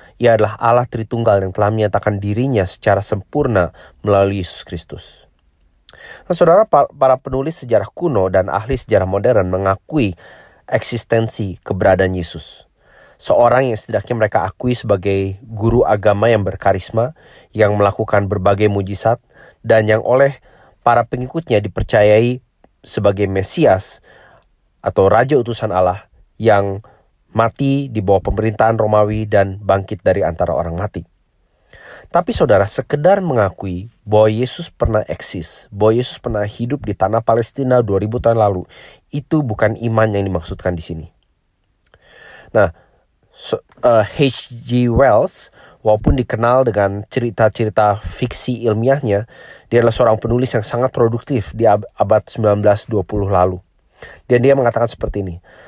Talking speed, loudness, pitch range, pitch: 125 wpm, -16 LUFS, 100-120 Hz, 110 Hz